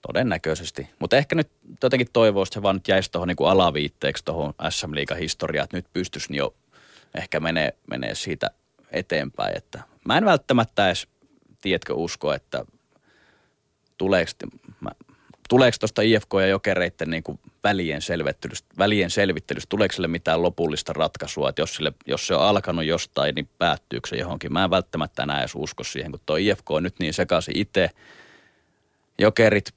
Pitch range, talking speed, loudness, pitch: 80-105 Hz, 150 wpm, -23 LUFS, 90 Hz